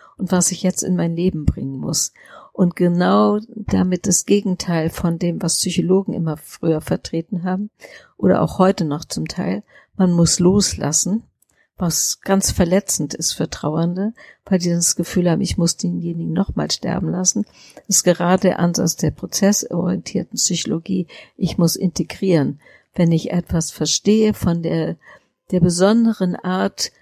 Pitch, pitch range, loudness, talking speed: 180 Hz, 170-195 Hz, -19 LUFS, 150 wpm